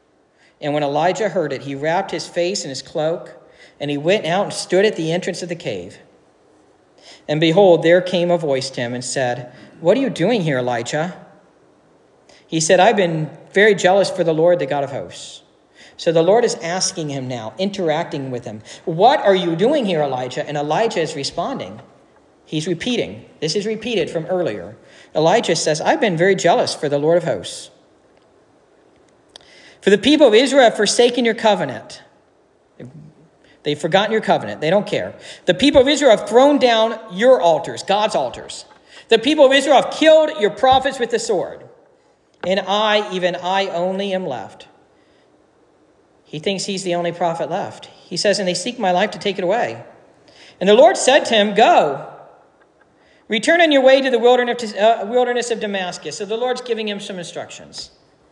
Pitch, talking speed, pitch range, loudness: 185 Hz, 180 wpm, 160-225 Hz, -17 LUFS